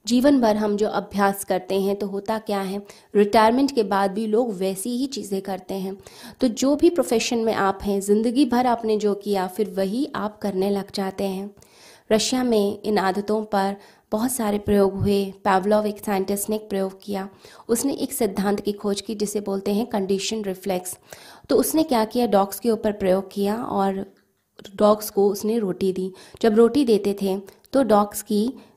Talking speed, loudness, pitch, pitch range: 185 wpm, -22 LUFS, 205 Hz, 195-225 Hz